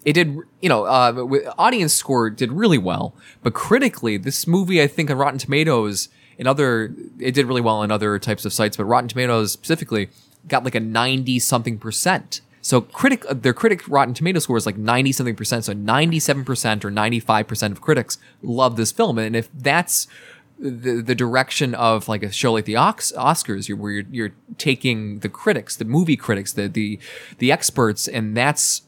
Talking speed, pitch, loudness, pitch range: 185 wpm, 125 Hz, -20 LUFS, 110-140 Hz